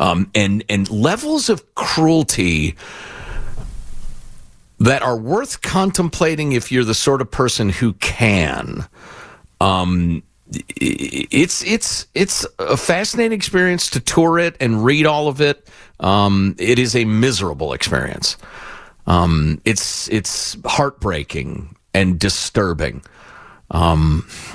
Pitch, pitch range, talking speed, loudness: 110 Hz, 95-155 Hz, 110 wpm, -17 LUFS